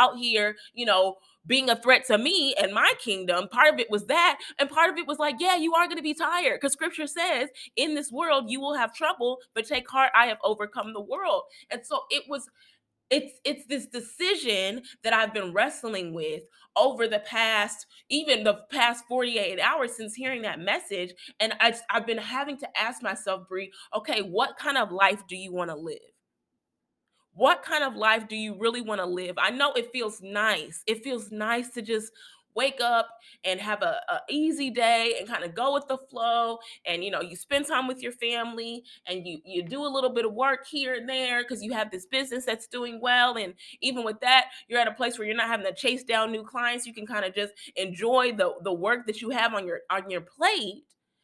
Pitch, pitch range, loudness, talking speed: 235 Hz, 210-270 Hz, -26 LUFS, 225 wpm